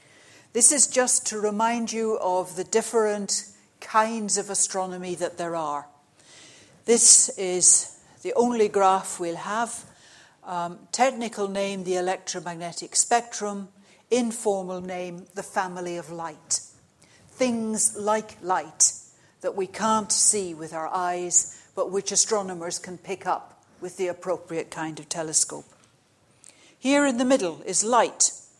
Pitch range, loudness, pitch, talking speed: 175-220 Hz, -23 LUFS, 195 Hz, 130 wpm